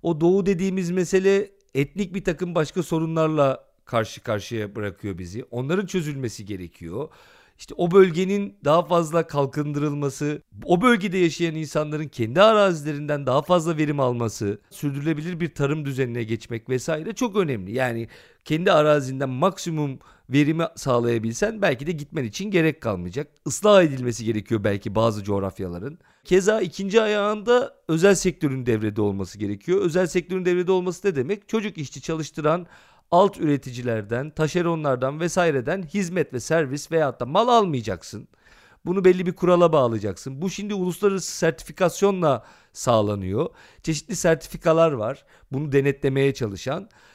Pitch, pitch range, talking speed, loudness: 155 Hz, 130-185 Hz, 130 wpm, -23 LUFS